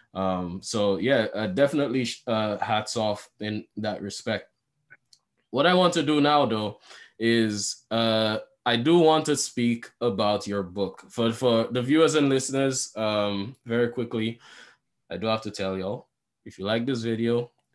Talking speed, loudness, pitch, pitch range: 165 wpm, -25 LUFS, 115 Hz, 105-130 Hz